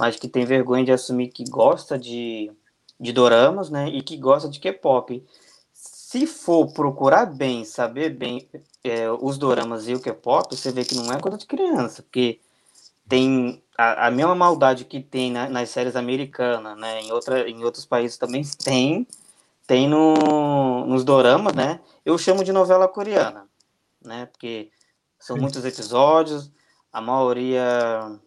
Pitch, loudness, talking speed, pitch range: 130 Hz, -21 LUFS, 155 wpm, 120-145 Hz